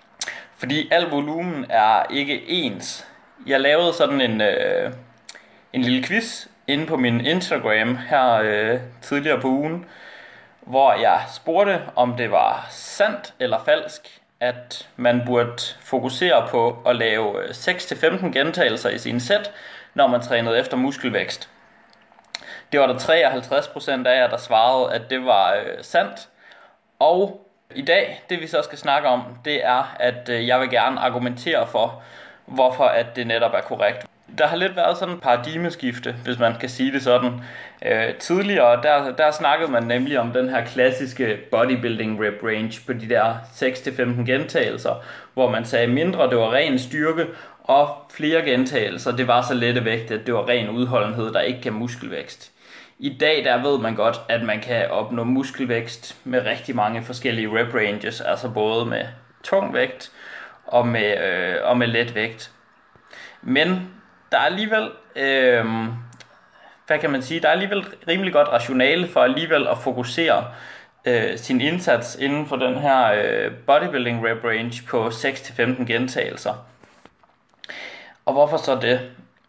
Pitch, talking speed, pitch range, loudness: 125 Hz, 155 wpm, 120-145 Hz, -21 LUFS